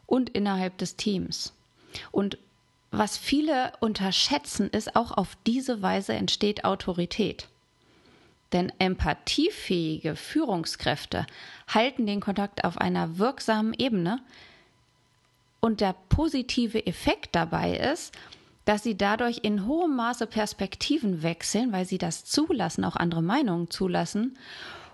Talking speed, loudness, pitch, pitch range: 115 wpm, -27 LUFS, 210 Hz, 185-240 Hz